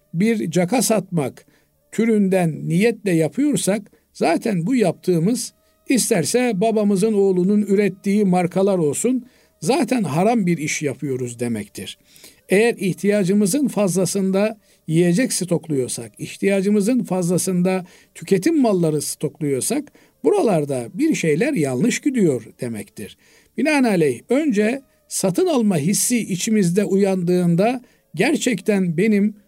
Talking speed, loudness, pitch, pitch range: 95 wpm, -19 LUFS, 195 Hz, 175-225 Hz